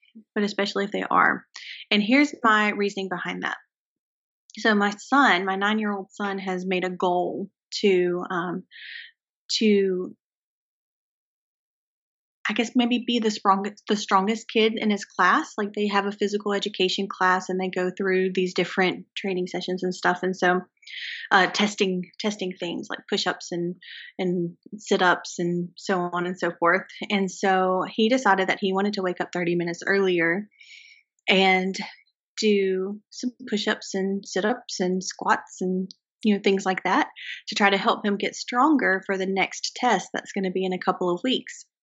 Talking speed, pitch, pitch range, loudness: 170 wpm, 195 Hz, 185-210 Hz, -24 LUFS